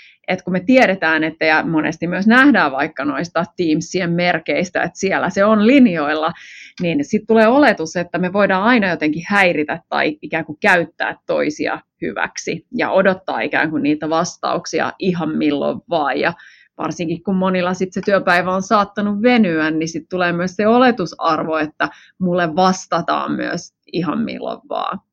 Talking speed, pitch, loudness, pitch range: 160 wpm, 180 Hz, -17 LUFS, 160-200 Hz